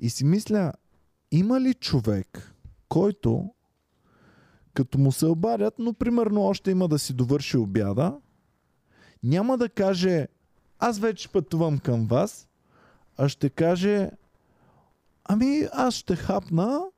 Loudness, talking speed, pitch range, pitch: -25 LUFS, 120 wpm, 135-210 Hz, 170 Hz